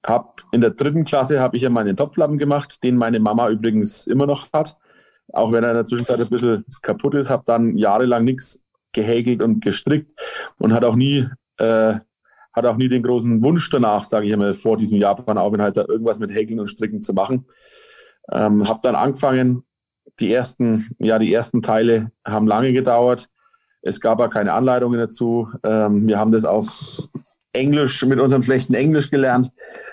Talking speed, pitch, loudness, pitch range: 185 wpm, 120 Hz, -18 LUFS, 110-135 Hz